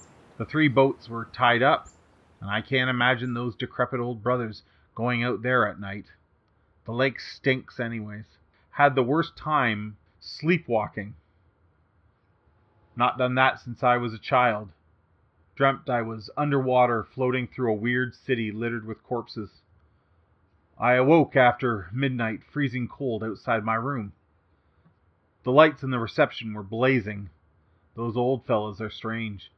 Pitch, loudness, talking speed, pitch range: 115 Hz, -25 LUFS, 140 wpm, 100-125 Hz